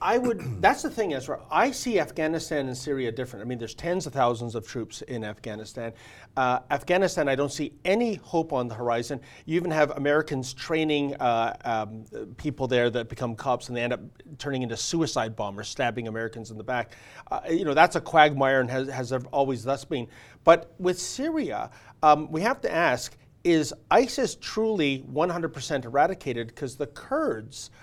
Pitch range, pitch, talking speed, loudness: 120-155 Hz, 135 Hz, 185 wpm, -26 LUFS